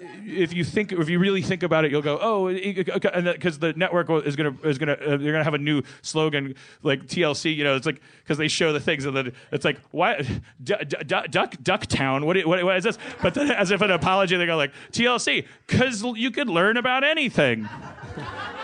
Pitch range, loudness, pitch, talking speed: 150-195 Hz, -23 LUFS, 170 Hz, 205 wpm